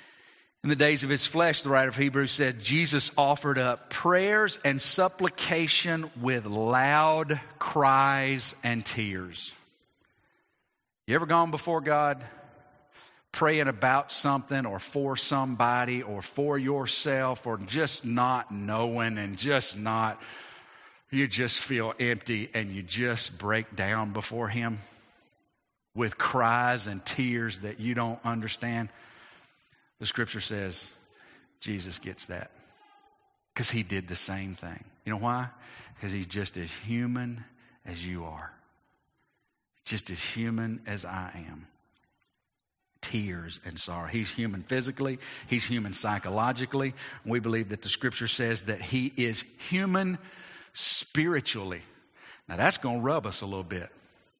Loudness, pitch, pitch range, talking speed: -28 LUFS, 120 Hz, 105-140 Hz, 130 wpm